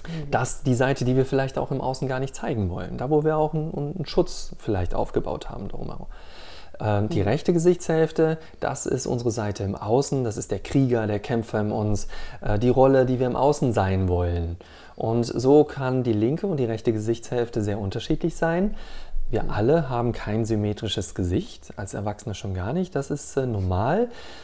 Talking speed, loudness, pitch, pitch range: 185 wpm, -24 LUFS, 125 Hz, 105-145 Hz